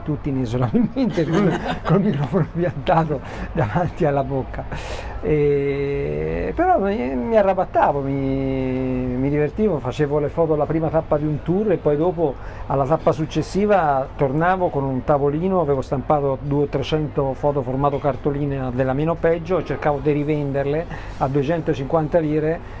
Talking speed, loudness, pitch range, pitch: 135 wpm, -21 LUFS, 140-165 Hz, 150 Hz